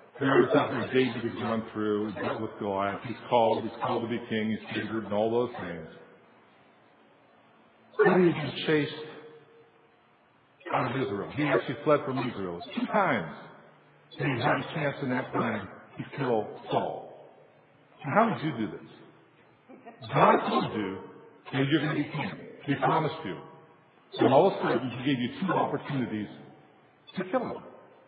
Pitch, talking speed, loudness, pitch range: 125 Hz, 175 wpm, -28 LUFS, 110-150 Hz